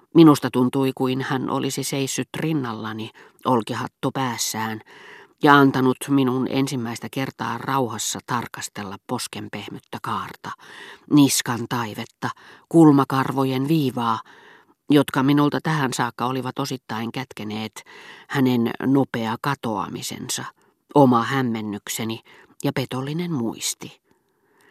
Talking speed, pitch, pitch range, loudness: 90 wpm, 130 Hz, 115-140 Hz, -22 LUFS